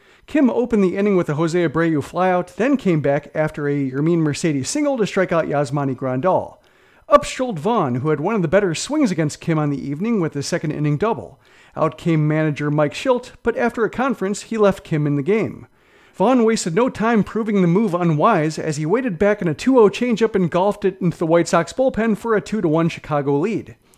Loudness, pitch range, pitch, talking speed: -19 LUFS, 155-220 Hz, 175 Hz, 220 wpm